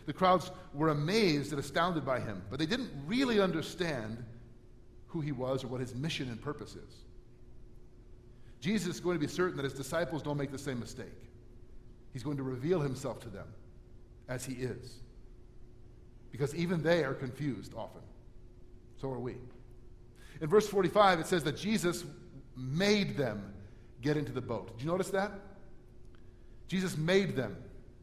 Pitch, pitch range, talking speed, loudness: 135 Hz, 120-165 Hz, 165 wpm, -34 LUFS